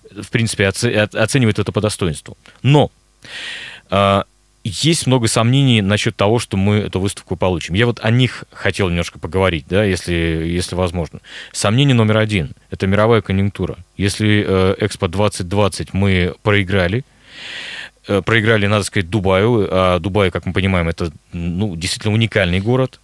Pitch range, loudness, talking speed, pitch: 95-110 Hz, -17 LUFS, 140 wpm, 100 Hz